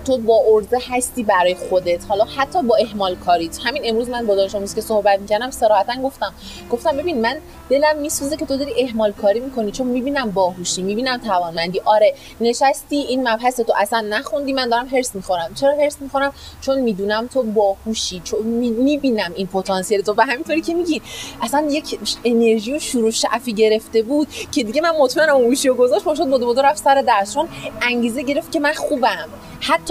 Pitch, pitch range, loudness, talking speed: 240 Hz, 215-280 Hz, -18 LUFS, 175 wpm